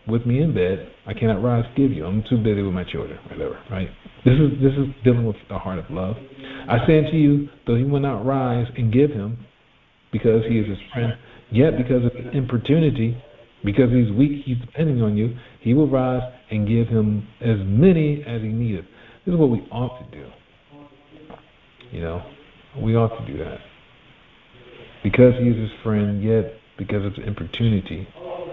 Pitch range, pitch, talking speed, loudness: 110-135 Hz, 120 Hz, 190 wpm, -21 LUFS